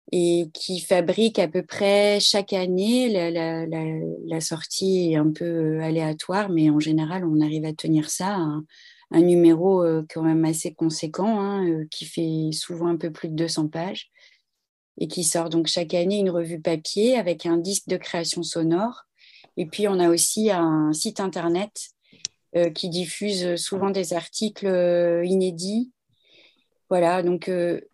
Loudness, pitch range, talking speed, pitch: -23 LUFS, 165-190 Hz, 160 wpm, 175 Hz